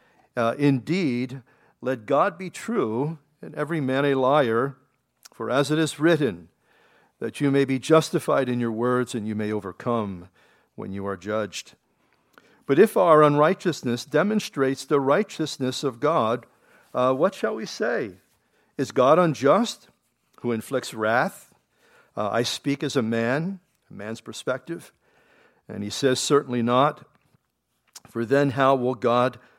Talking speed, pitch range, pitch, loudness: 145 wpm, 120-150 Hz, 130 Hz, -23 LUFS